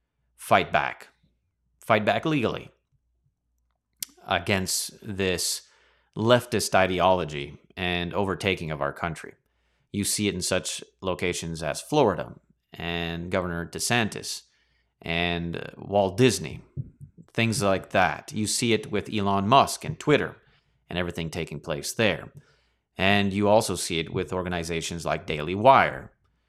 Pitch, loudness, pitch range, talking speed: 90 Hz, -25 LUFS, 85-100 Hz, 120 wpm